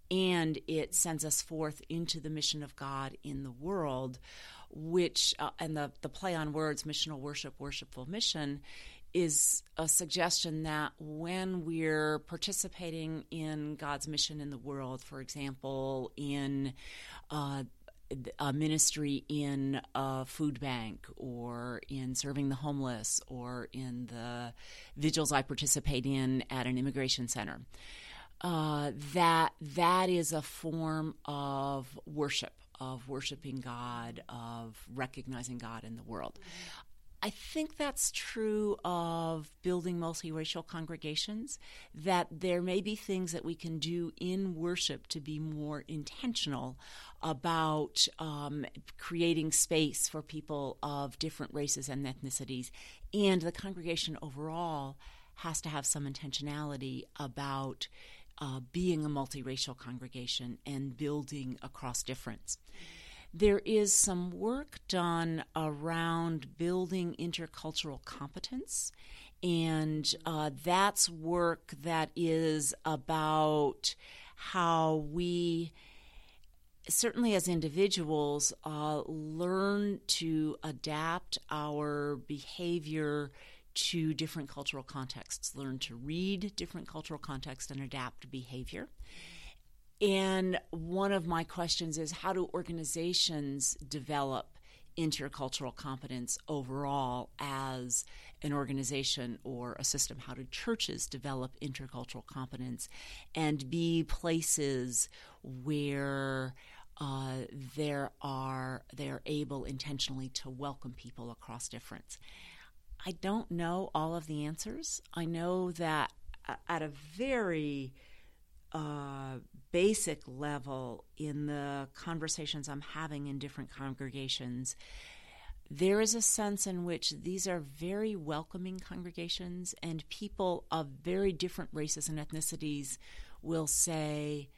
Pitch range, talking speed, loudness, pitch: 135-165 Hz, 115 wpm, -35 LUFS, 150 Hz